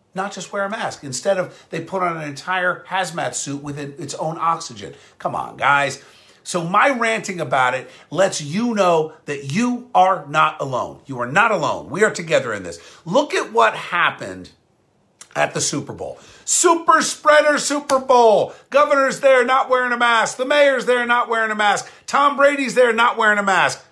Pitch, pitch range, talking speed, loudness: 200 Hz, 160-250 Hz, 190 wpm, -18 LUFS